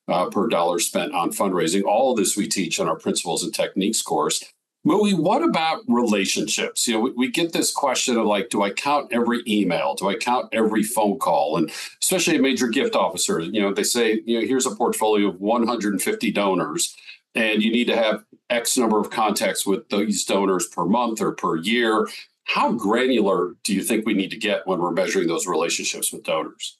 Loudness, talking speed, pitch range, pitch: -21 LUFS, 210 wpm, 105-125 Hz, 115 Hz